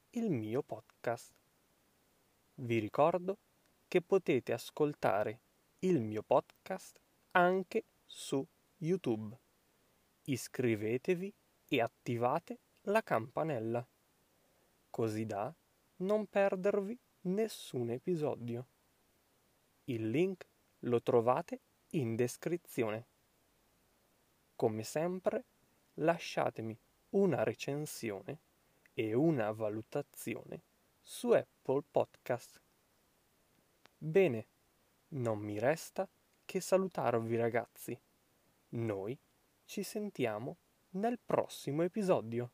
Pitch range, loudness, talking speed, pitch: 115-190 Hz, -36 LUFS, 80 wpm, 145 Hz